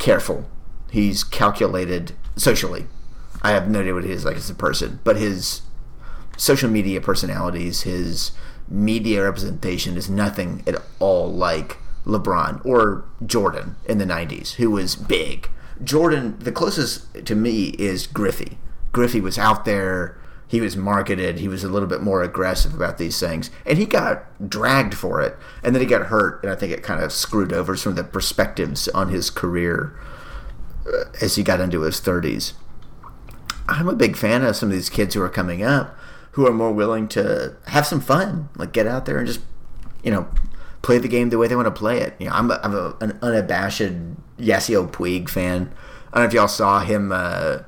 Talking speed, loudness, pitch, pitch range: 190 wpm, -21 LUFS, 105 Hz, 90-120 Hz